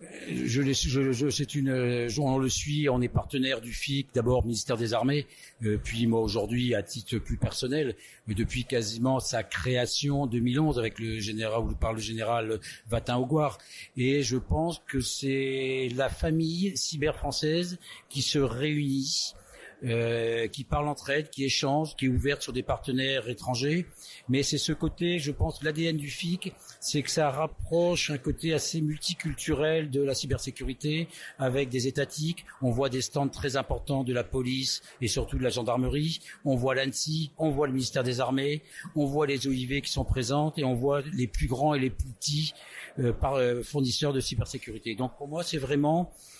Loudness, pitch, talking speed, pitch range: -29 LUFS, 135 Hz, 180 wpm, 125-150 Hz